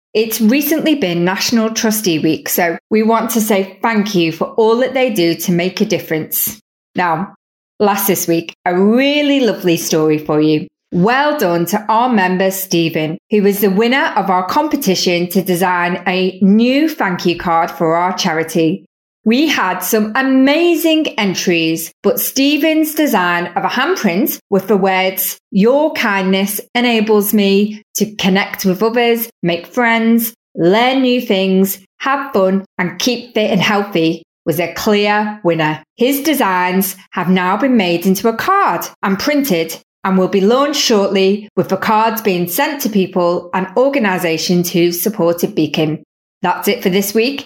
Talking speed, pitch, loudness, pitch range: 160 wpm, 195 Hz, -14 LUFS, 180-230 Hz